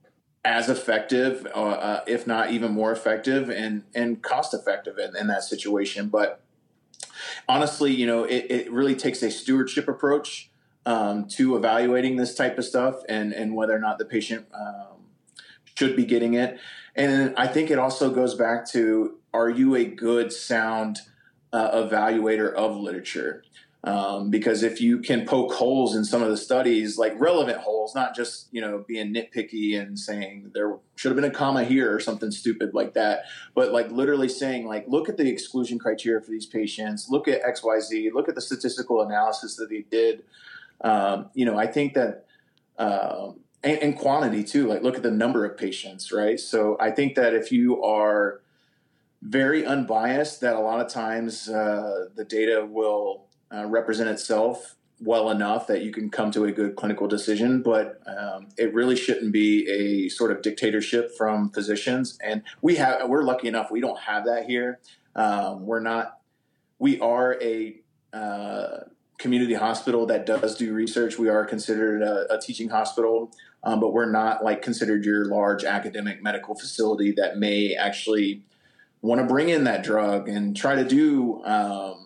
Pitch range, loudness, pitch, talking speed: 105-130 Hz, -24 LUFS, 115 Hz, 175 wpm